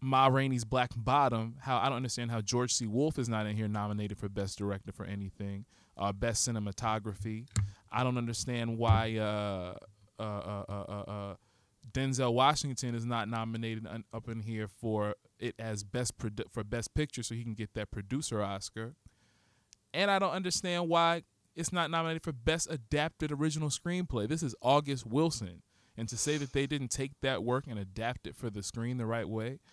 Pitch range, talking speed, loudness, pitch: 105-135 Hz, 190 wpm, -34 LUFS, 115 Hz